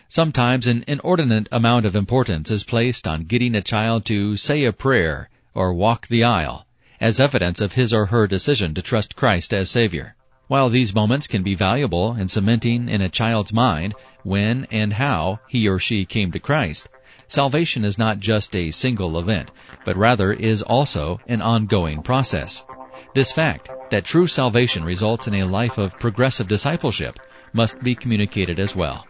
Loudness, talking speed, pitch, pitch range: -20 LUFS, 175 wpm, 115 Hz, 100-130 Hz